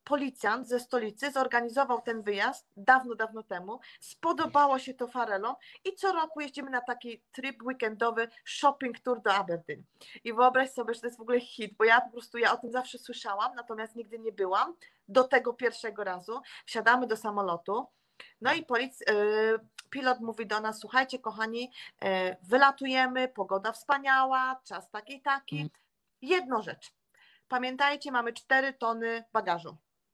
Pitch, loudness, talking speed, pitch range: 240 Hz, -30 LUFS, 150 wpm, 220-260 Hz